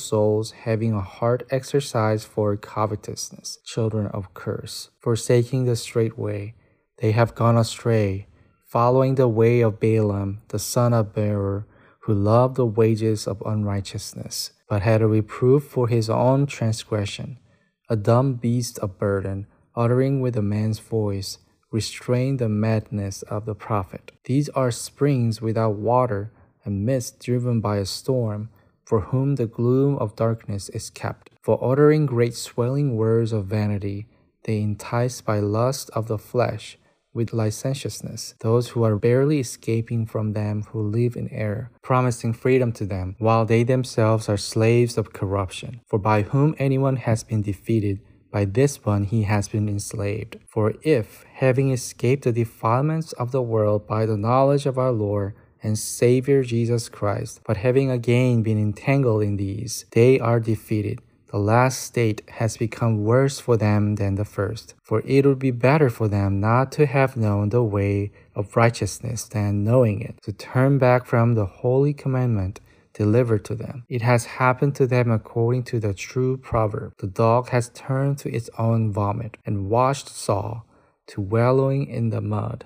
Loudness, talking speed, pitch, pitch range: -22 LUFS, 160 wpm, 115 Hz, 105-125 Hz